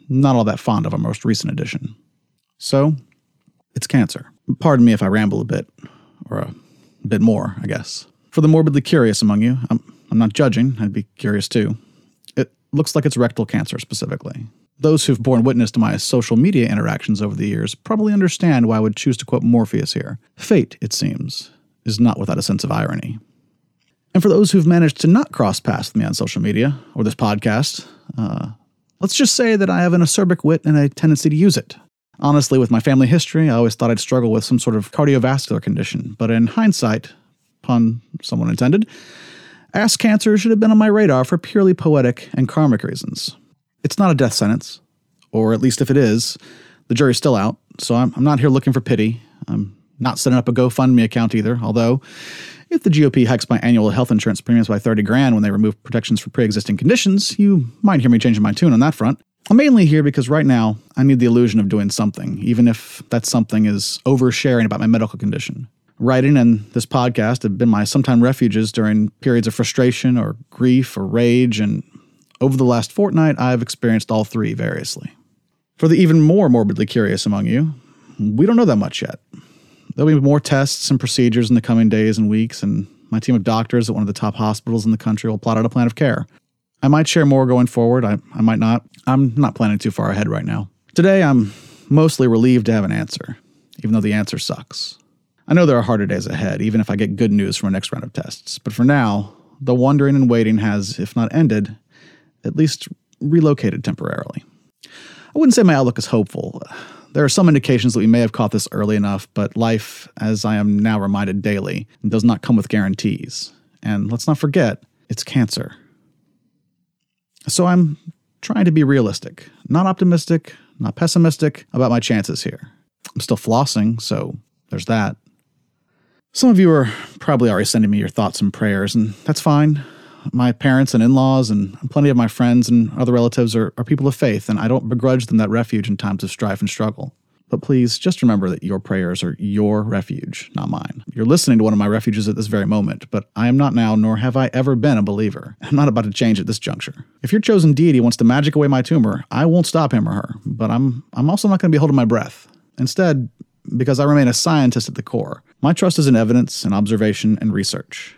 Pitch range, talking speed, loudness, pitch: 110-150 Hz, 215 wpm, -16 LUFS, 125 Hz